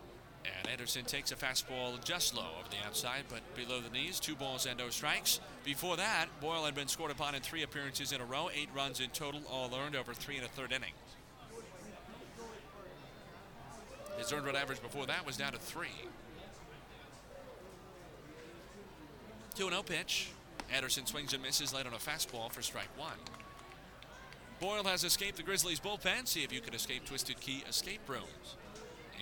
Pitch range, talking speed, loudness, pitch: 130-160 Hz, 170 wpm, -37 LUFS, 140 Hz